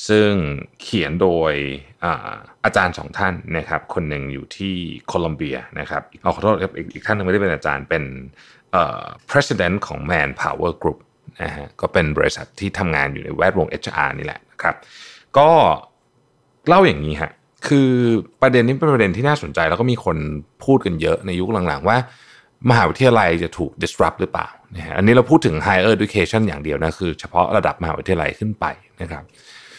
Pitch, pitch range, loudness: 95 Hz, 80-120 Hz, -19 LUFS